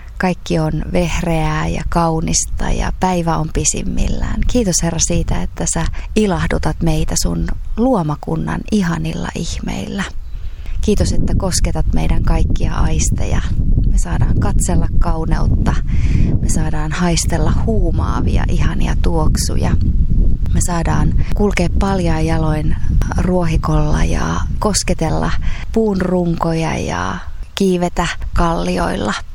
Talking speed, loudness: 100 wpm, -18 LUFS